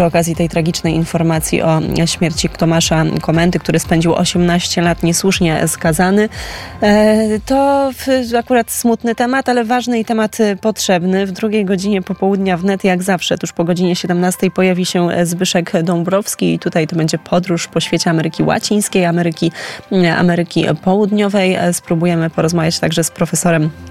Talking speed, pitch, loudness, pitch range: 140 wpm, 180 Hz, -14 LUFS, 170-200 Hz